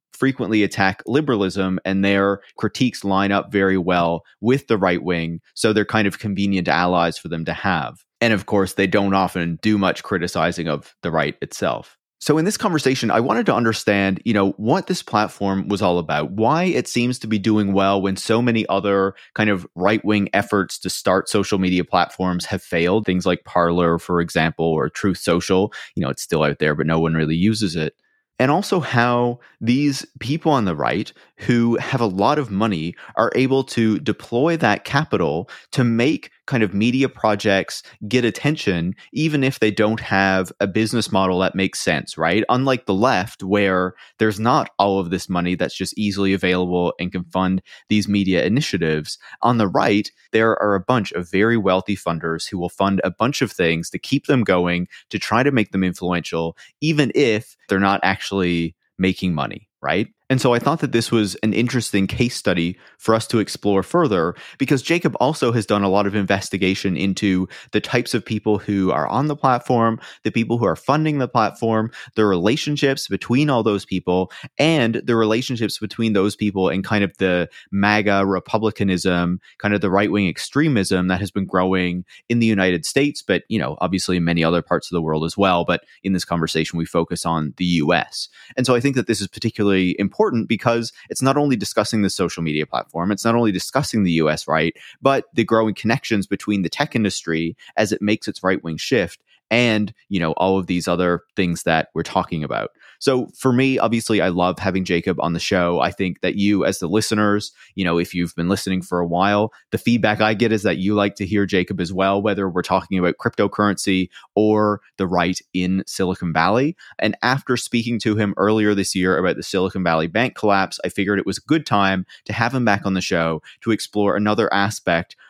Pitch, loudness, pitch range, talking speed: 100 Hz, -20 LUFS, 90-115 Hz, 205 wpm